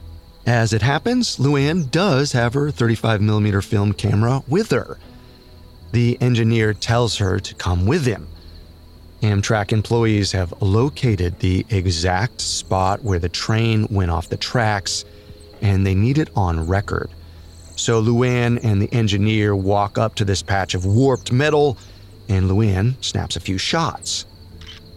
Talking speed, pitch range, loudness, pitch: 140 wpm, 95-115 Hz, -19 LUFS, 105 Hz